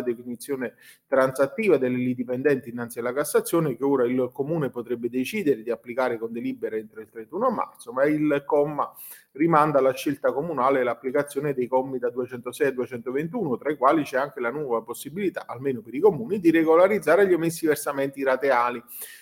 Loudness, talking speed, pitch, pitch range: -24 LUFS, 165 wpm, 130 Hz, 125-145 Hz